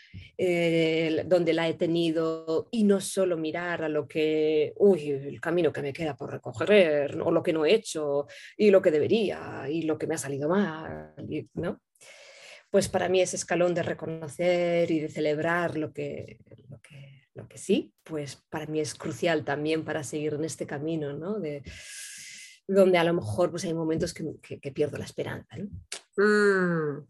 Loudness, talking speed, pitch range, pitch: -27 LUFS, 185 wpm, 150-175 Hz, 160 Hz